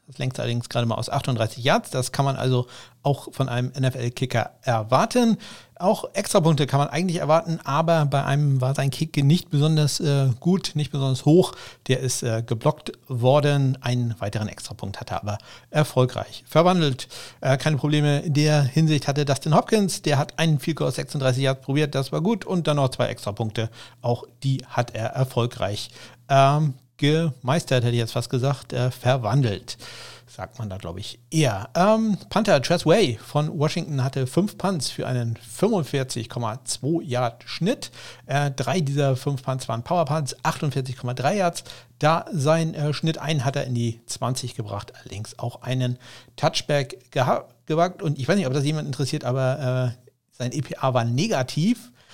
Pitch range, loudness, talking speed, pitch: 125-155 Hz, -23 LUFS, 170 wpm, 135 Hz